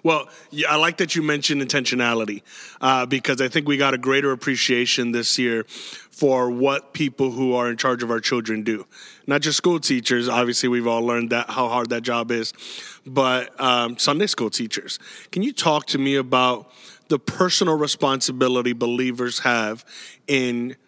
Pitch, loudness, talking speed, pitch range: 130 Hz, -21 LUFS, 170 wpm, 120-140 Hz